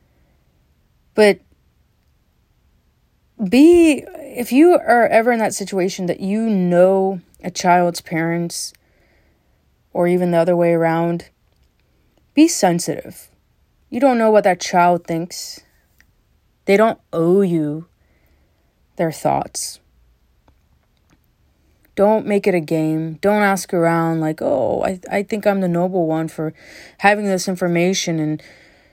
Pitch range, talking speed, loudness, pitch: 160-200 Hz, 120 wpm, -17 LUFS, 175 Hz